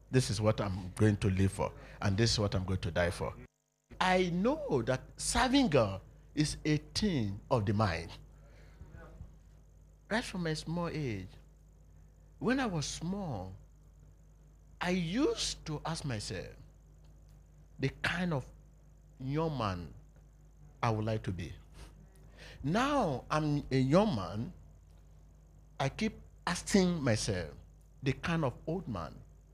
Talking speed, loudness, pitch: 135 wpm, -33 LUFS, 115 Hz